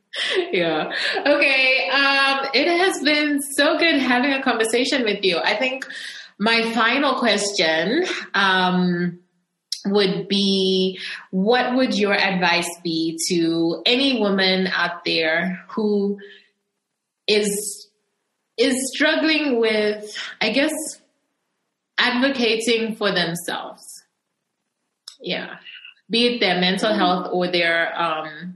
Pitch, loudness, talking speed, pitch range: 210 Hz, -19 LUFS, 105 wpm, 185-265 Hz